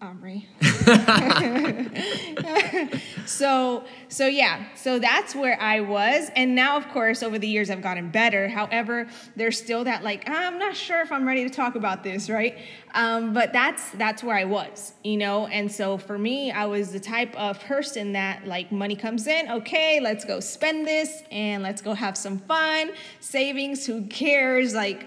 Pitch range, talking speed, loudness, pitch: 205-270 Hz, 175 wpm, -24 LUFS, 230 Hz